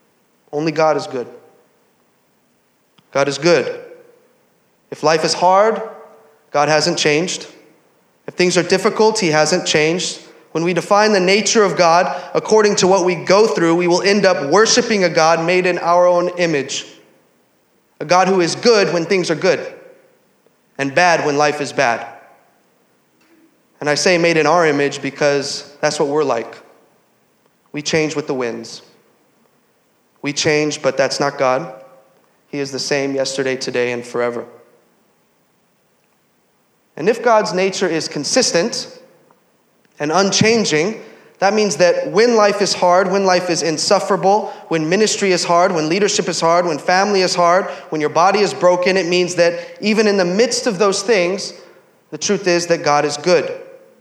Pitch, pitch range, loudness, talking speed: 175 Hz, 150-200 Hz, -15 LUFS, 160 wpm